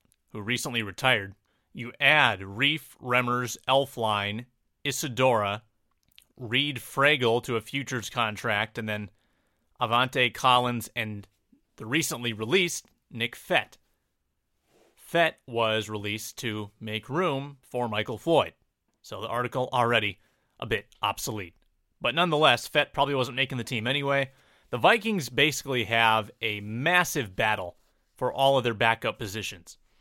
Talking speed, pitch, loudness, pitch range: 125 wpm, 120 Hz, -26 LUFS, 110-135 Hz